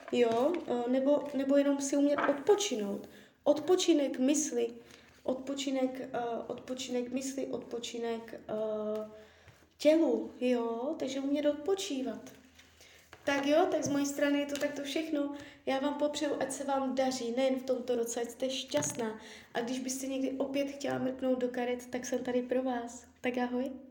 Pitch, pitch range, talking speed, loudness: 265 Hz, 245-285 Hz, 145 wpm, -33 LUFS